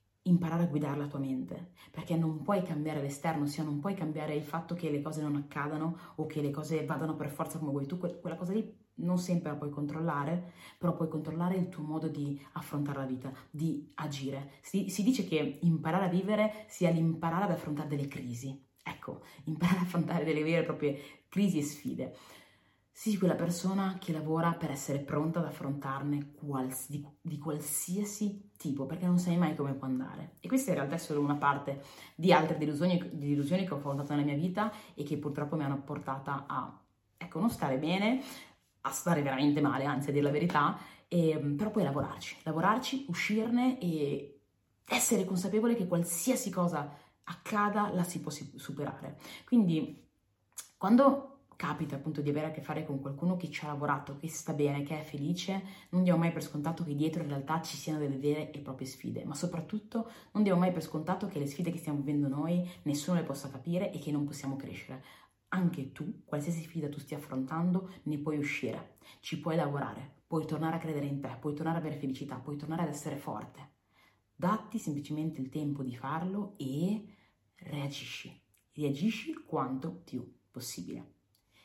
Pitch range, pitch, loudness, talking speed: 145-175 Hz, 155 Hz, -34 LUFS, 190 wpm